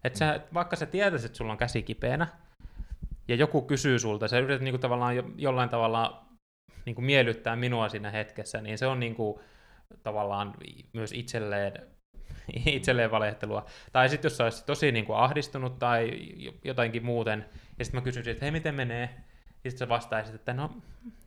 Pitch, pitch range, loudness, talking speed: 120 Hz, 110-135 Hz, -30 LUFS, 165 wpm